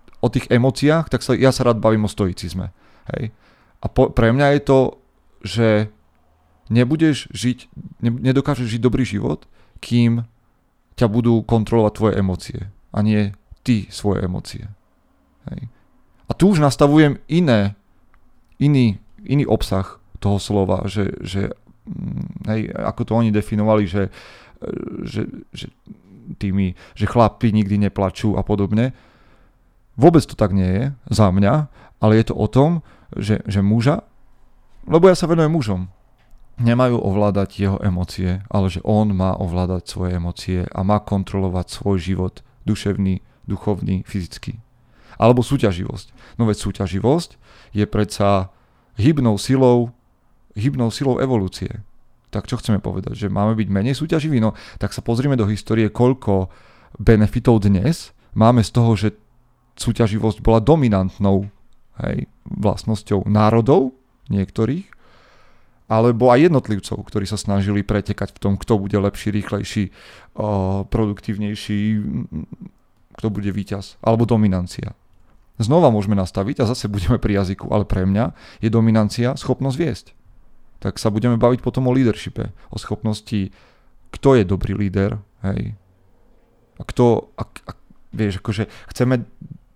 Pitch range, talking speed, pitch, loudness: 100-120 Hz, 130 wpm, 110 Hz, -19 LUFS